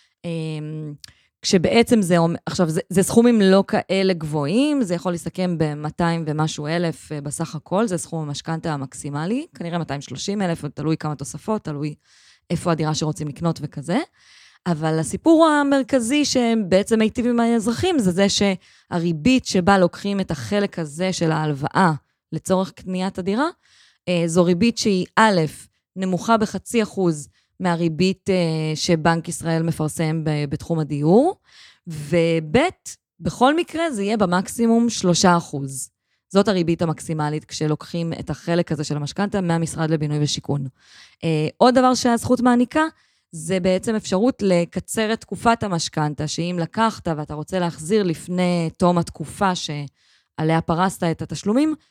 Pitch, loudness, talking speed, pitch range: 175 Hz, -21 LUFS, 130 wpm, 155-205 Hz